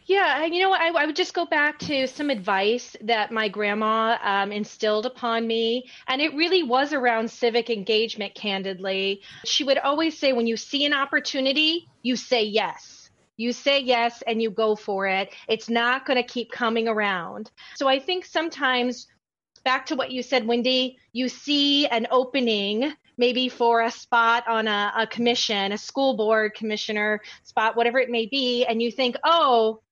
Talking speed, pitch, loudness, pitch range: 180 wpm, 240 Hz, -23 LUFS, 220-275 Hz